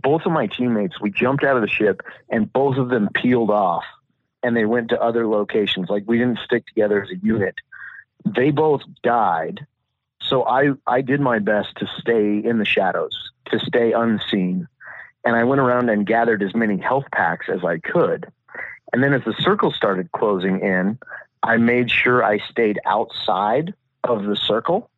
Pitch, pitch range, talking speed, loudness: 115 Hz, 105-130 Hz, 185 wpm, -20 LUFS